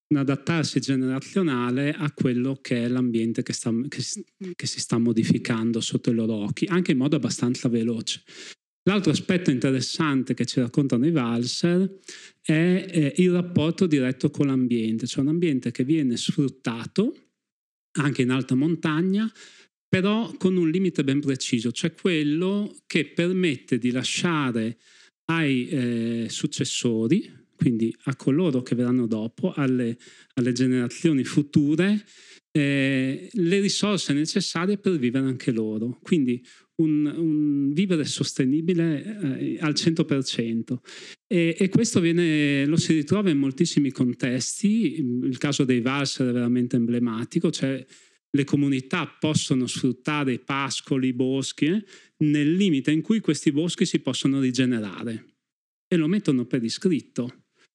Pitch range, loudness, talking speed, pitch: 125-165 Hz, -24 LUFS, 135 wpm, 140 Hz